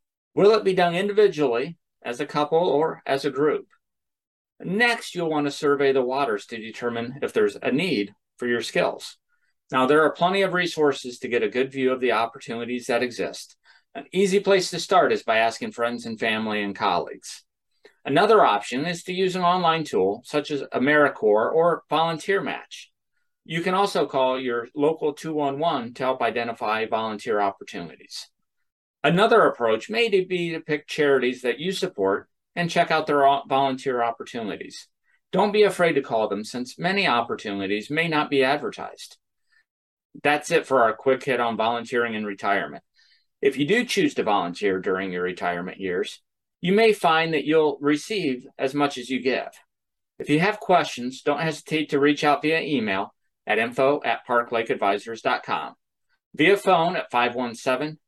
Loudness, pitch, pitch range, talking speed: -23 LUFS, 145 Hz, 120-170 Hz, 170 wpm